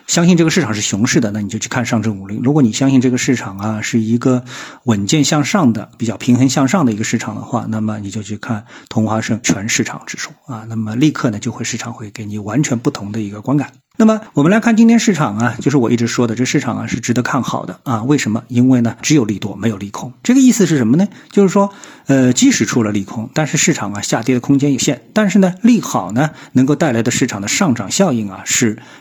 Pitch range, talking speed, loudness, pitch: 110-150 Hz, 370 characters per minute, -15 LUFS, 125 Hz